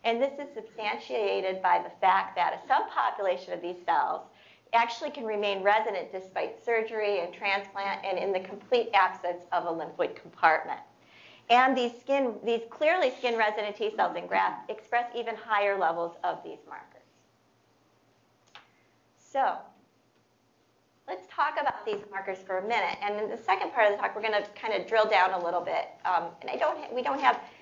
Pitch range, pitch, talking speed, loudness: 190-235 Hz, 210 Hz, 175 wpm, -29 LUFS